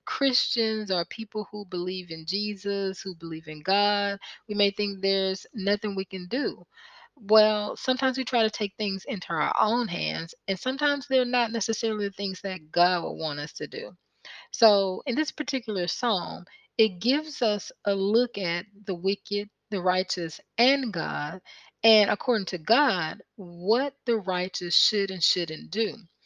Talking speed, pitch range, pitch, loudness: 165 wpm, 185-230 Hz, 205 Hz, -26 LUFS